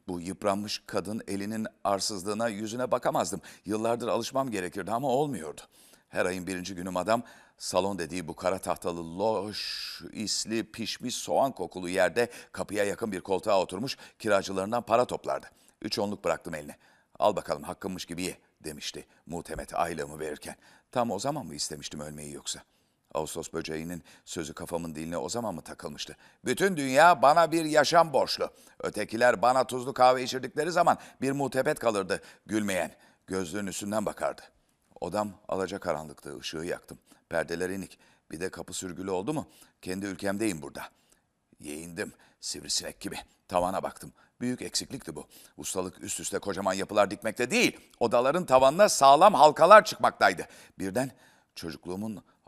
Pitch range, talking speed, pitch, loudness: 90-125 Hz, 140 wpm, 100 Hz, -28 LUFS